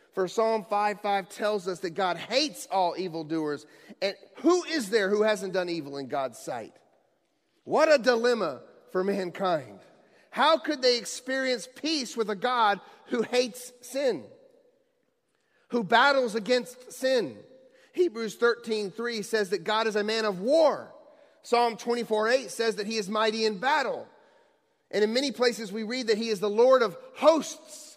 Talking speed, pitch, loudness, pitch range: 160 wpm, 230 Hz, -27 LUFS, 210-265 Hz